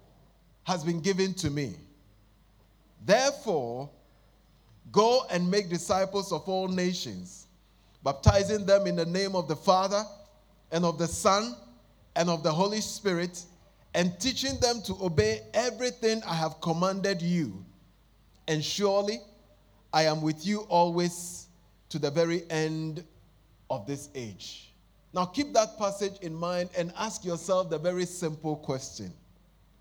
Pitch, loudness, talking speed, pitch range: 175 Hz, -29 LUFS, 135 wpm, 145-195 Hz